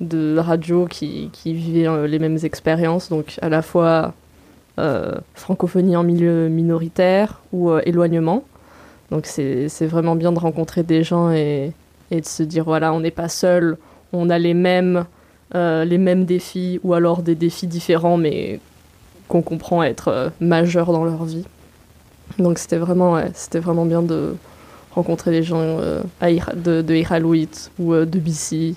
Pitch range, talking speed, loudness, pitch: 160-175 Hz, 170 wpm, -19 LUFS, 165 Hz